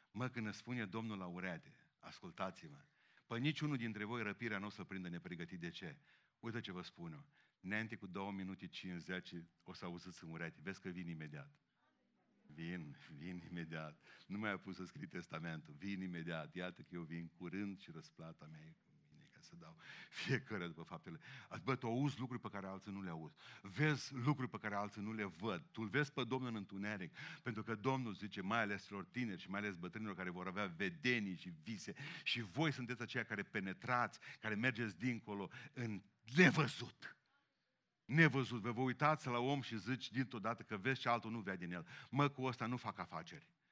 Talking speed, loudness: 195 wpm, -43 LUFS